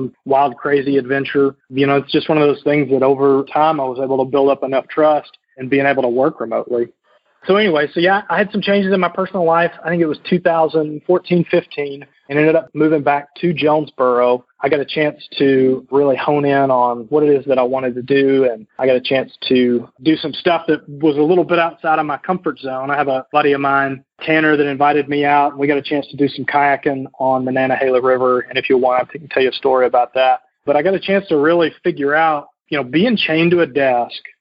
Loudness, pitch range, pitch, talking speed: -16 LUFS, 135-155 Hz, 145 Hz, 245 wpm